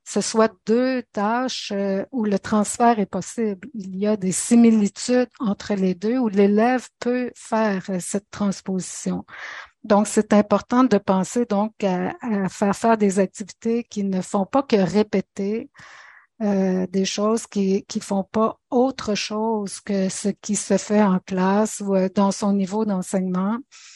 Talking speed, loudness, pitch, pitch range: 155 wpm, -22 LUFS, 210 Hz, 195-225 Hz